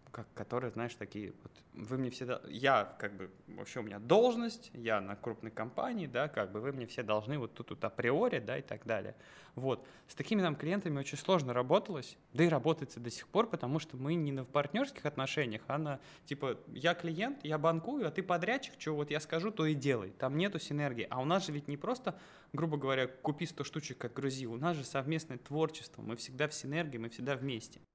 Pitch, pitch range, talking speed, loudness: 145 Hz, 125-165 Hz, 215 wpm, -36 LUFS